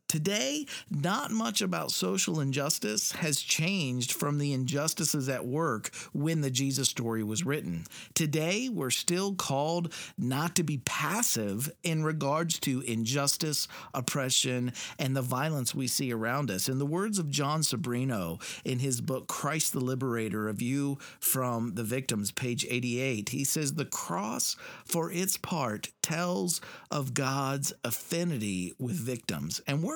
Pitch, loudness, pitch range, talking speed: 140 Hz, -30 LUFS, 125-165 Hz, 145 wpm